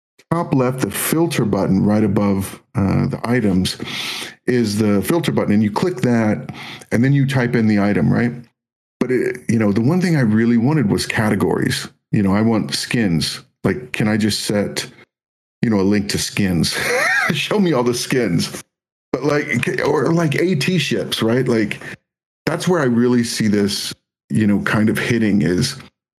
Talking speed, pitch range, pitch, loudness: 180 wpm, 105-140 Hz, 120 Hz, -18 LUFS